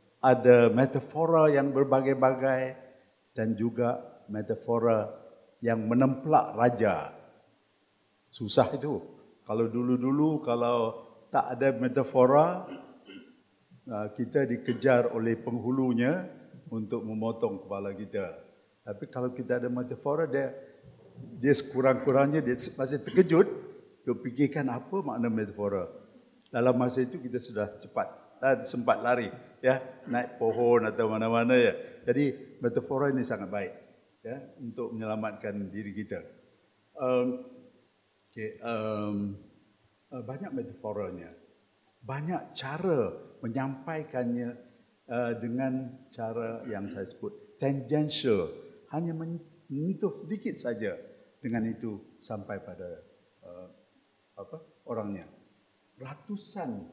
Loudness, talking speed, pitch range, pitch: -29 LUFS, 100 wpm, 115-145 Hz, 125 Hz